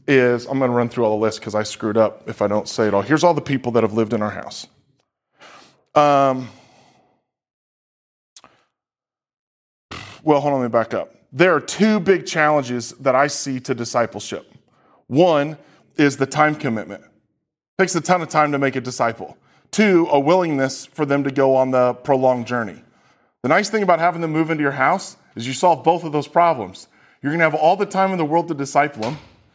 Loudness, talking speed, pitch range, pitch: -19 LUFS, 205 wpm, 120-160 Hz, 140 Hz